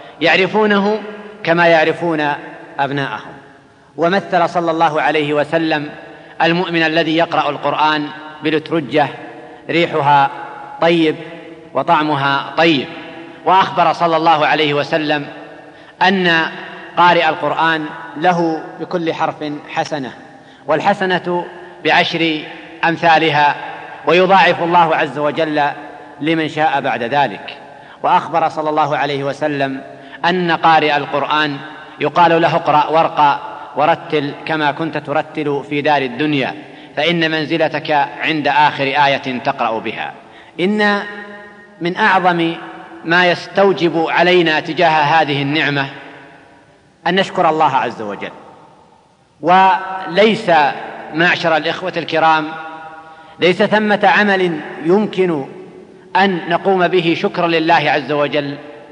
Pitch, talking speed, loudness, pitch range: 160 Hz, 100 wpm, -15 LUFS, 150-170 Hz